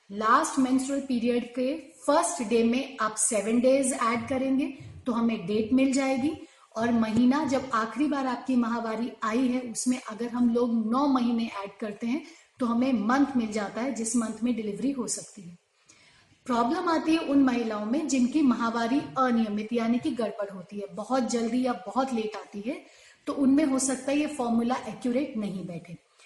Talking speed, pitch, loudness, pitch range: 180 wpm, 245 Hz, -27 LUFS, 225-265 Hz